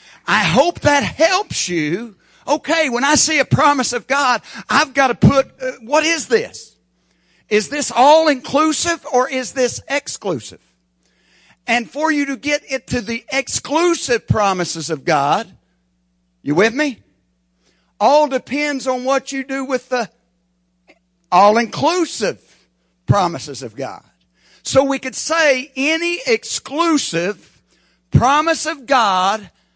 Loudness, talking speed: -16 LUFS, 135 wpm